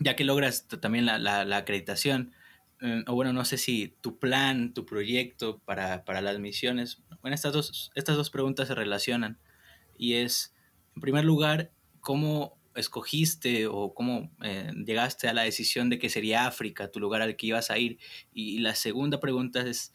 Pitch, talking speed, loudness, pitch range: 120 Hz, 185 wpm, -29 LUFS, 110-135 Hz